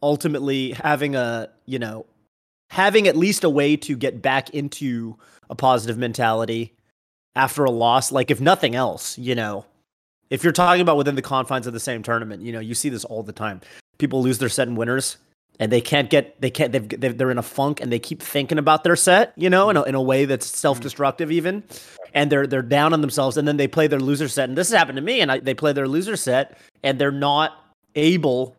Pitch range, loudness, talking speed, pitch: 120-150 Hz, -20 LUFS, 230 wpm, 135 Hz